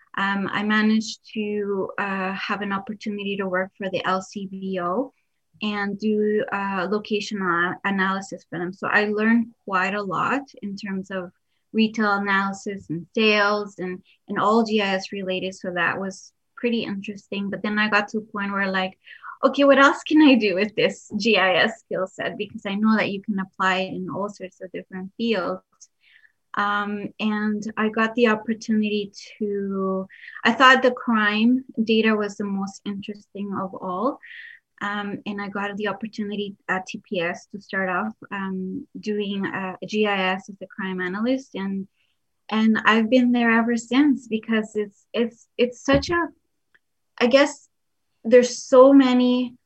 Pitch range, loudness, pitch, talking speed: 195-225 Hz, -22 LUFS, 205 Hz, 160 wpm